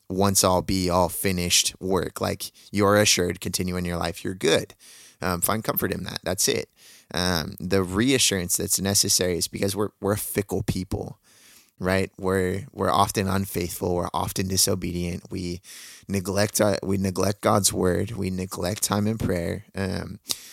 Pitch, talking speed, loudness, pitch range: 95 Hz, 160 wpm, -24 LUFS, 90-100 Hz